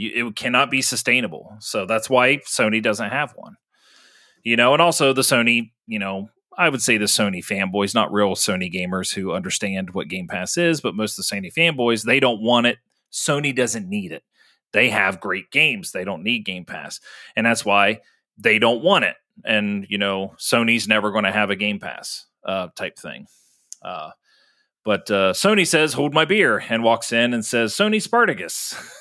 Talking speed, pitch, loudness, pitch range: 195 wpm, 115 Hz, -19 LUFS, 100-135 Hz